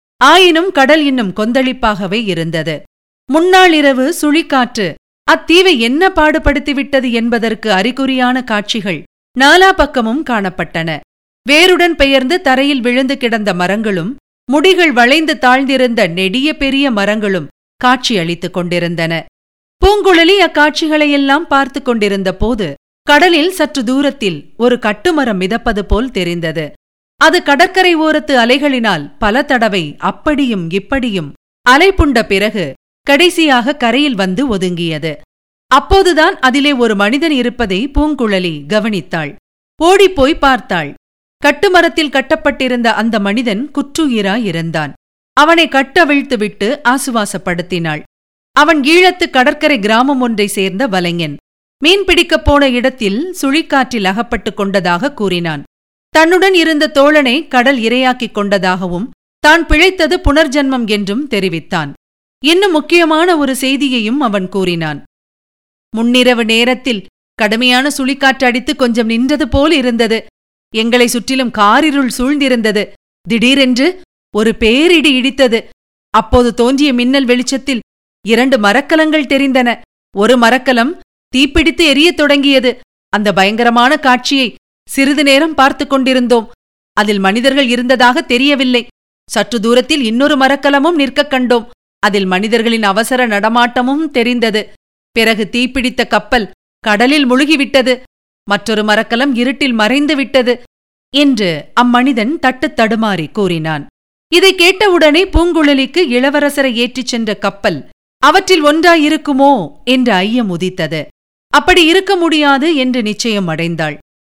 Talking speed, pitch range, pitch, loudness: 100 wpm, 215-290 Hz, 255 Hz, -11 LUFS